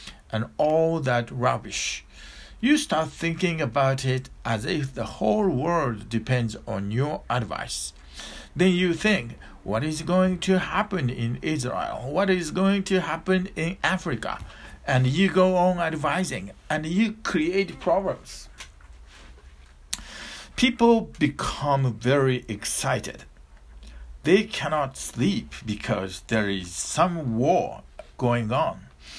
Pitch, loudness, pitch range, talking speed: 135 Hz, -25 LUFS, 105-180 Hz, 120 wpm